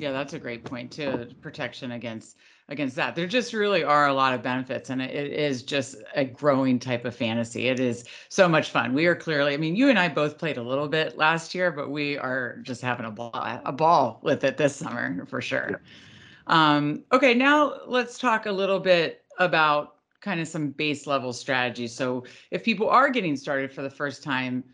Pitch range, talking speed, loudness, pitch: 130-165 Hz, 210 wpm, -25 LUFS, 145 Hz